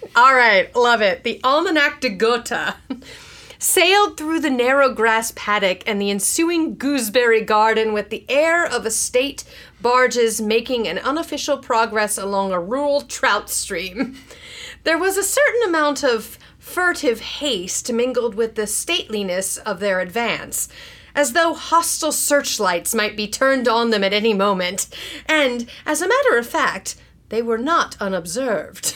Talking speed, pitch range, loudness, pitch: 150 wpm, 220-295 Hz, -18 LUFS, 245 Hz